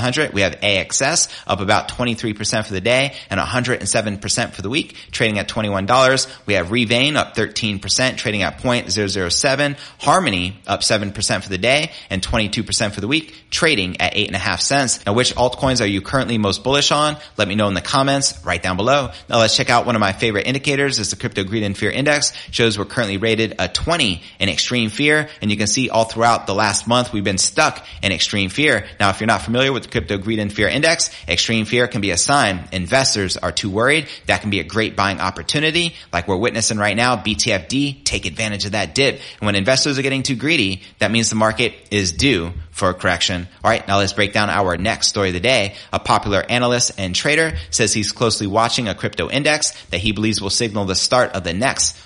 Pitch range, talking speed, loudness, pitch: 100-125 Hz, 235 wpm, -17 LUFS, 110 Hz